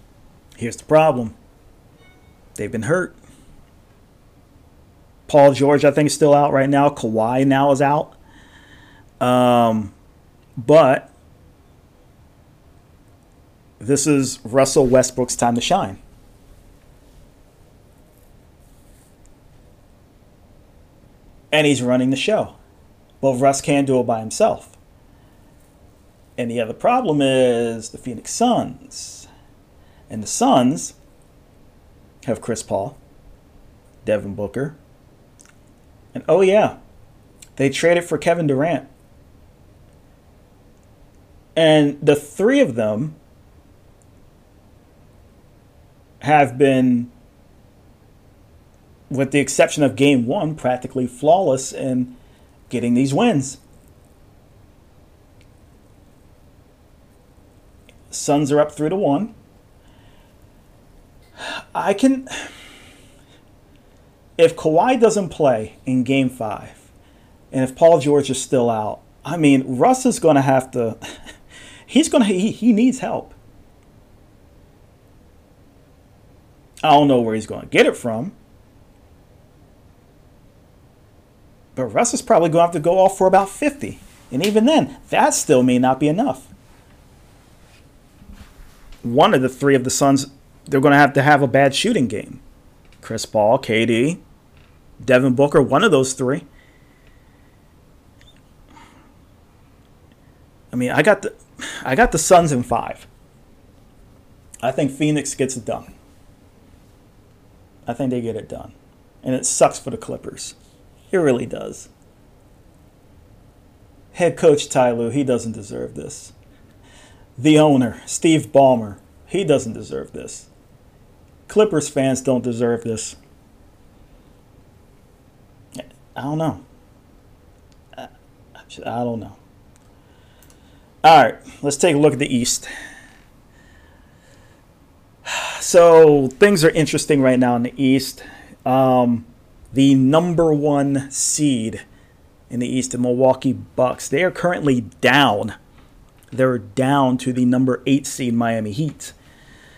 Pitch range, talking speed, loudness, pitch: 100-145 Hz, 110 wpm, -17 LUFS, 125 Hz